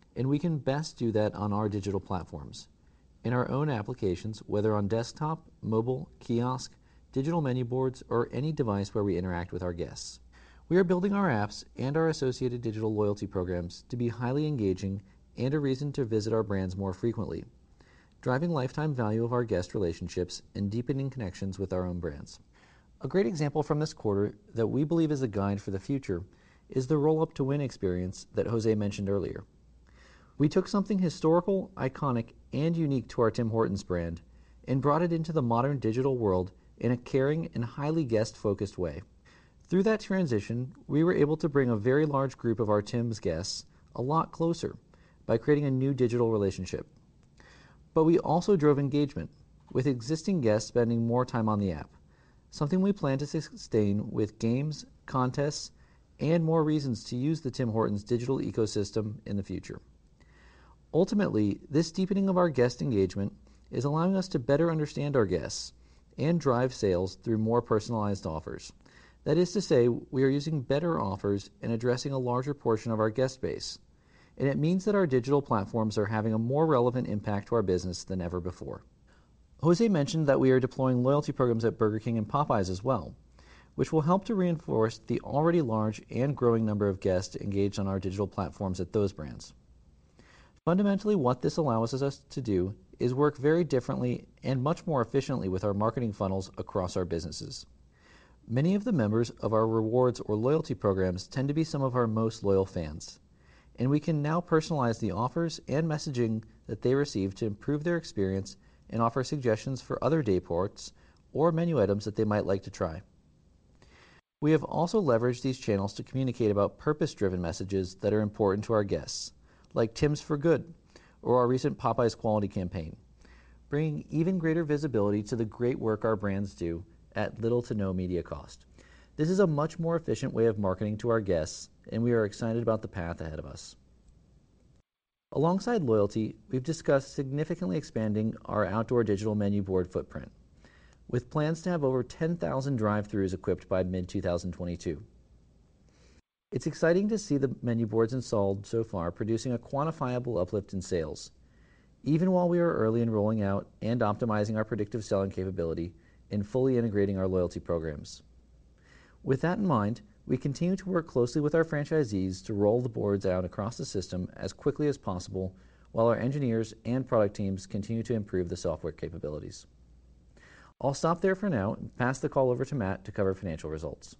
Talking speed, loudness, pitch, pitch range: 180 wpm, -30 LUFS, 115 Hz, 100-145 Hz